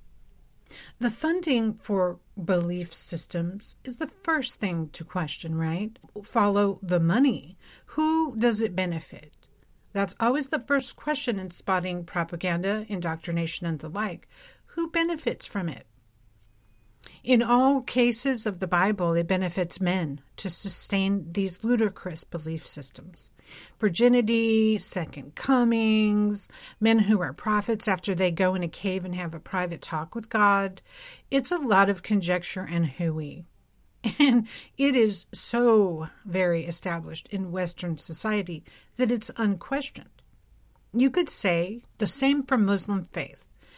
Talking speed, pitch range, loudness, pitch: 135 wpm, 170-230 Hz, -26 LUFS, 195 Hz